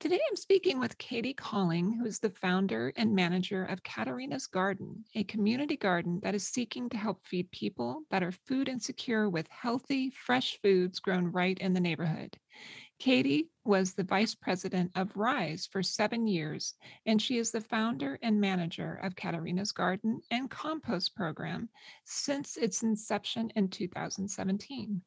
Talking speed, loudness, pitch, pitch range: 160 wpm, -32 LUFS, 205 Hz, 185-240 Hz